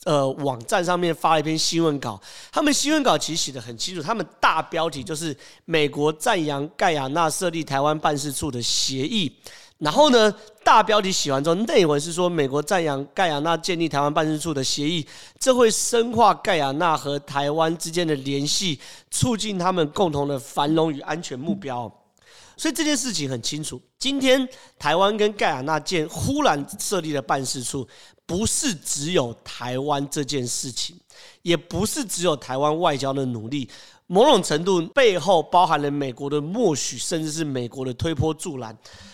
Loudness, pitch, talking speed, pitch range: -22 LUFS, 155 Hz, 275 characters per minute, 140-180 Hz